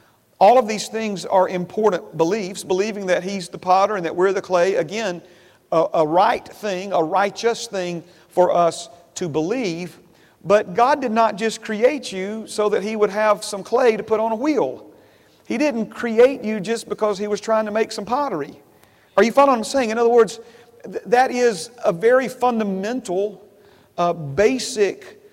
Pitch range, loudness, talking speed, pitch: 185-230 Hz, -20 LUFS, 185 wpm, 210 Hz